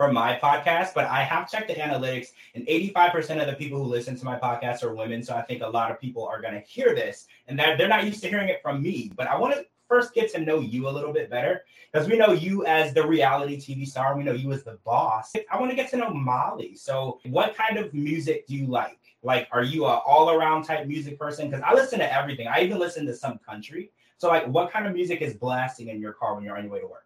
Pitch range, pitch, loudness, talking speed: 125-175 Hz, 150 Hz, -25 LUFS, 270 wpm